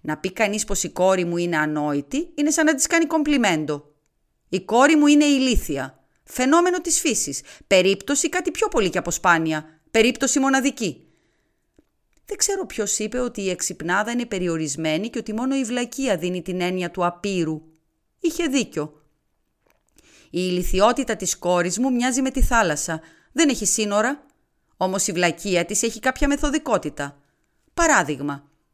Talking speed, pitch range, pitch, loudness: 150 wpm, 170-270 Hz, 205 Hz, -21 LUFS